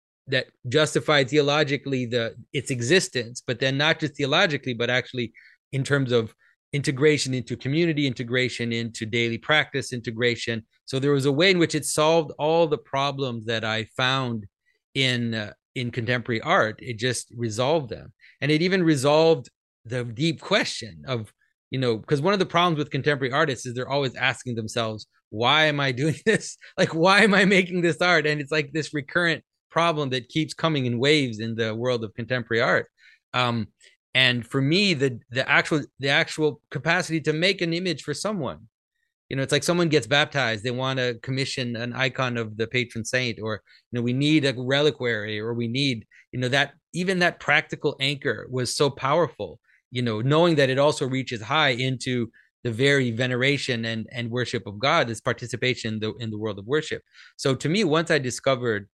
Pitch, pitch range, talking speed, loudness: 135 Hz, 120-155 Hz, 190 wpm, -23 LUFS